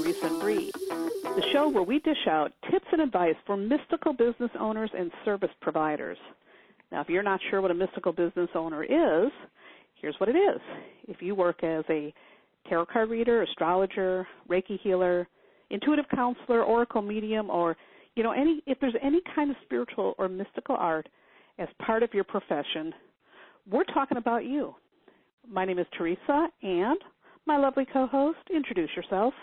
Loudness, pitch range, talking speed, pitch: -28 LUFS, 180-285 Hz, 165 wpm, 220 Hz